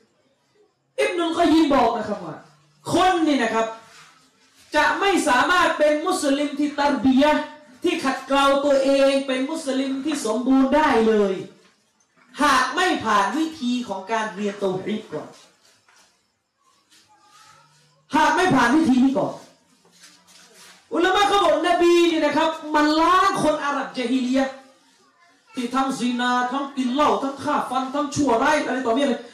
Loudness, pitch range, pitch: -20 LUFS, 250-310 Hz, 275 Hz